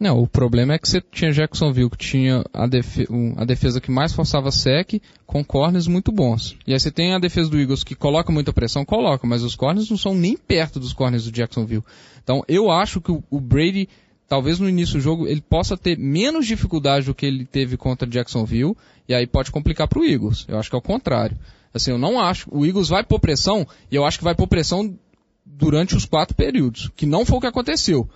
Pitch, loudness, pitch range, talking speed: 145 Hz, -20 LUFS, 125-170 Hz, 225 wpm